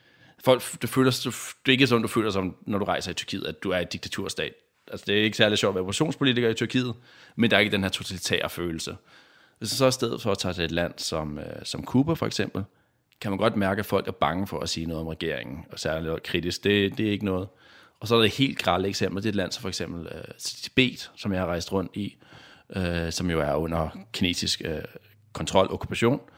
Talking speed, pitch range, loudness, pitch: 250 wpm, 90-115 Hz, -26 LUFS, 100 Hz